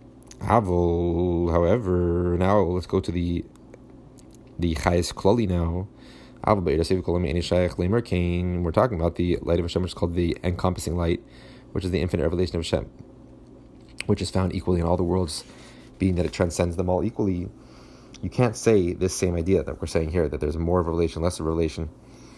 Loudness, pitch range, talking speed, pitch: -24 LUFS, 85-95 Hz, 175 wpm, 90 Hz